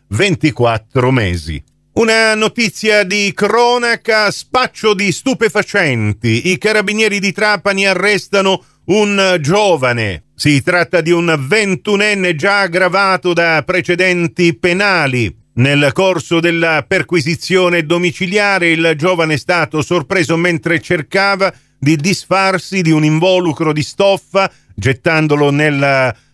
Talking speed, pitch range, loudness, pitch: 105 wpm, 155-200 Hz, -13 LUFS, 180 Hz